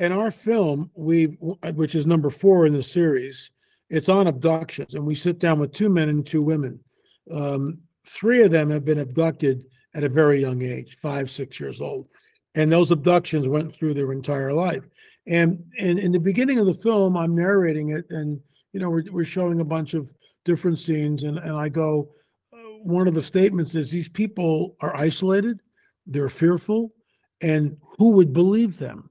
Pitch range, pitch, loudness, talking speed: 150-180 Hz, 165 Hz, -22 LUFS, 185 wpm